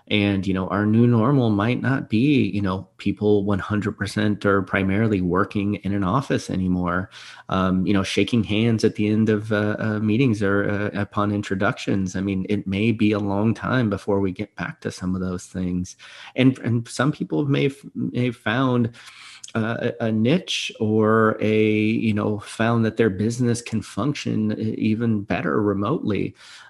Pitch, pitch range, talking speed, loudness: 105 Hz, 100-115 Hz, 175 wpm, -22 LUFS